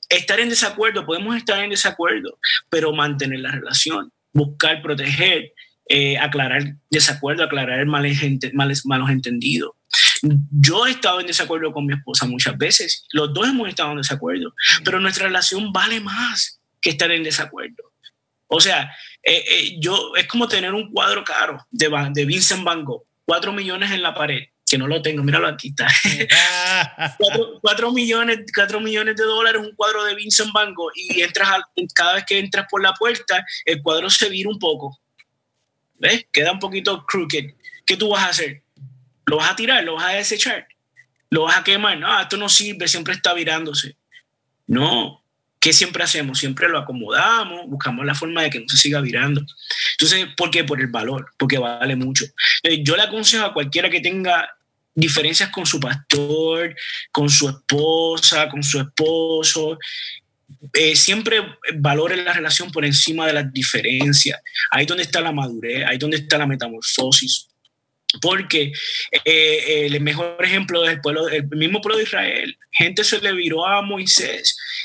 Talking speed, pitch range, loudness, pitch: 170 wpm, 145-195 Hz, -17 LUFS, 160 Hz